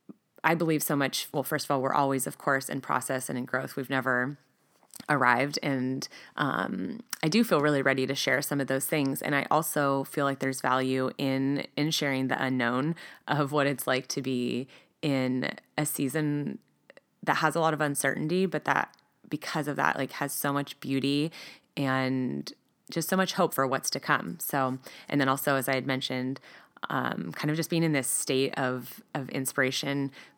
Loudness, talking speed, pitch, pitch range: -29 LUFS, 195 wpm, 140 Hz, 130-150 Hz